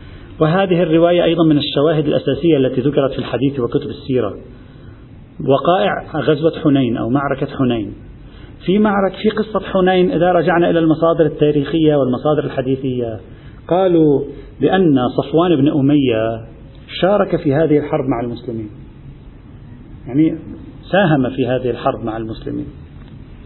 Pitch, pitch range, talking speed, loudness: 140 Hz, 125-160 Hz, 125 wpm, -16 LUFS